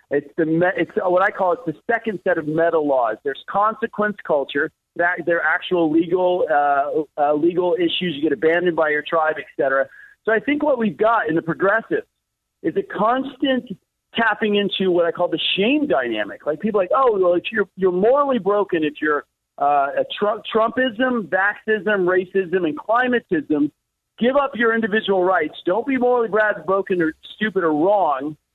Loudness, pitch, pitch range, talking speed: -20 LUFS, 190 Hz, 165-230 Hz, 185 wpm